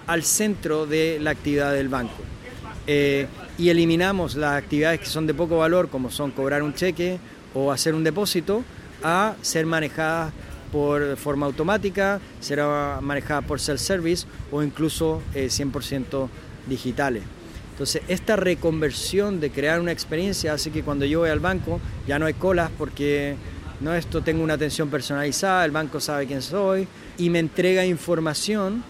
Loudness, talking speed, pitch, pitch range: -24 LUFS, 160 wpm, 155 Hz, 140-170 Hz